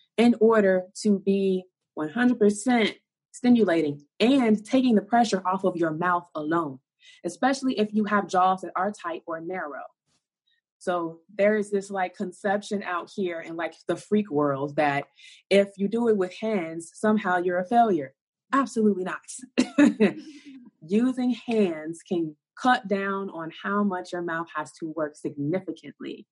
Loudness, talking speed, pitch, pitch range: -25 LUFS, 150 wpm, 195 Hz, 165-220 Hz